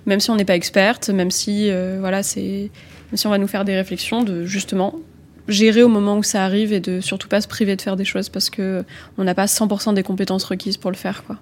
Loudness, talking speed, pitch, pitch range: -19 LUFS, 265 wpm, 195 Hz, 190-210 Hz